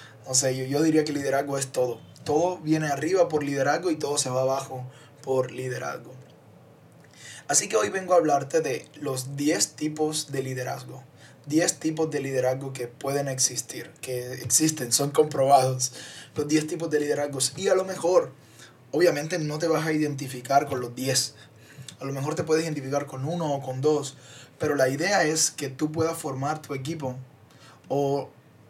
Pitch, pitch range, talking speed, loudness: 140 Hz, 130-155 Hz, 175 wpm, -26 LUFS